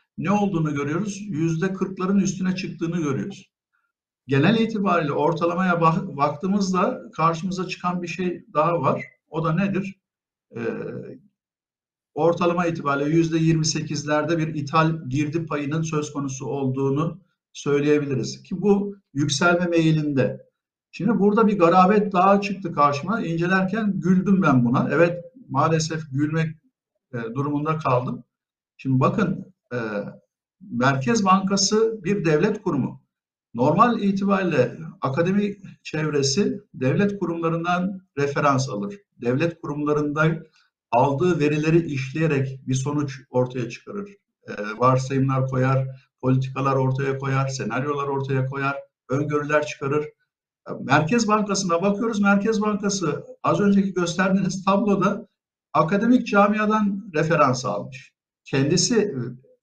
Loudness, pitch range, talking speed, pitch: -22 LUFS, 140-195 Hz, 105 wpm, 165 Hz